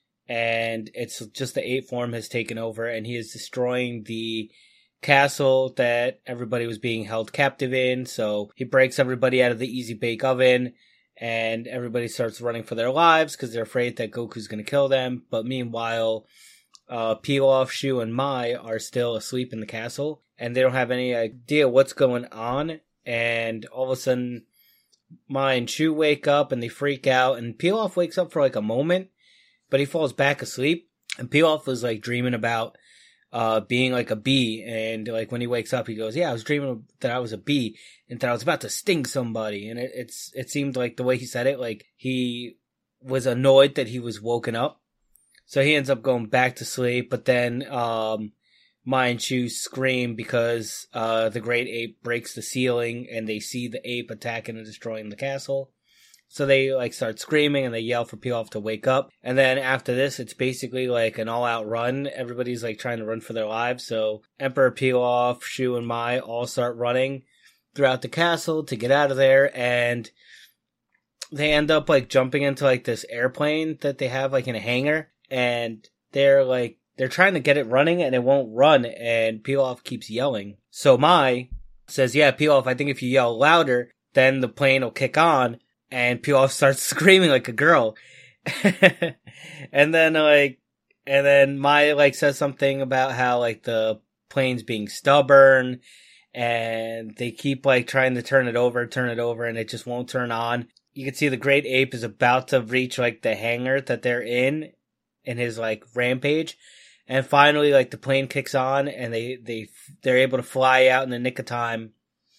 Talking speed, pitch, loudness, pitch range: 195 wpm, 125 Hz, -22 LUFS, 115-135 Hz